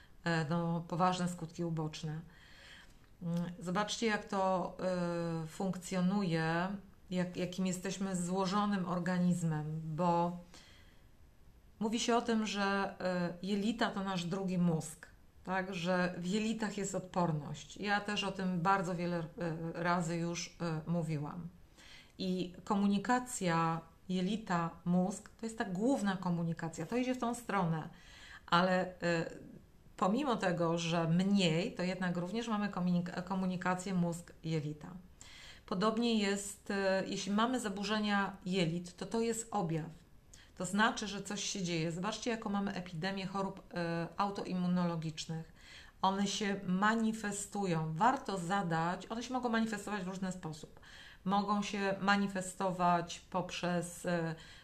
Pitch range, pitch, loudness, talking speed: 170-200 Hz, 185 Hz, -36 LUFS, 110 wpm